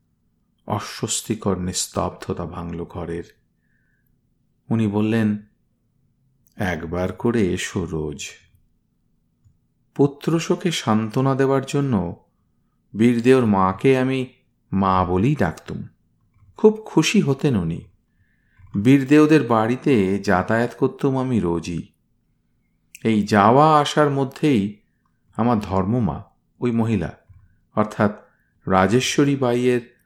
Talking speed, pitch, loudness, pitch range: 80 wpm, 115 Hz, -20 LUFS, 95-135 Hz